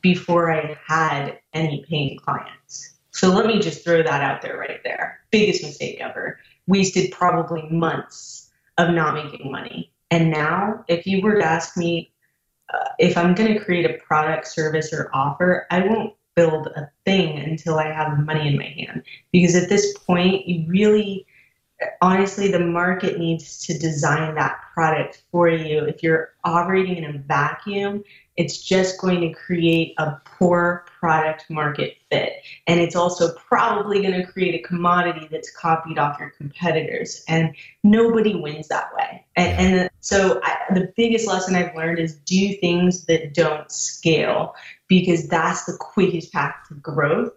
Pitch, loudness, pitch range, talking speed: 170 Hz, -20 LUFS, 155-185 Hz, 165 wpm